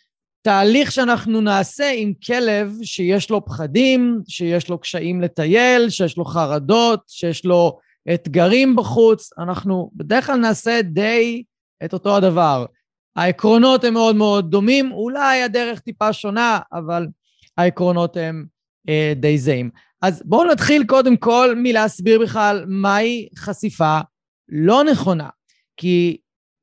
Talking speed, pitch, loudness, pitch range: 120 wpm, 205 Hz, -17 LUFS, 175-230 Hz